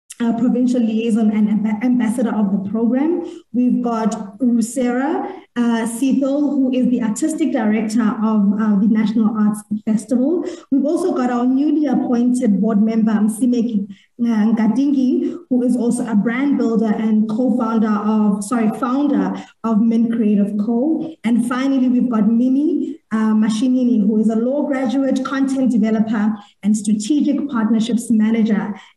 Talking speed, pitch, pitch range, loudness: 140 wpm, 235 Hz, 220-260 Hz, -17 LUFS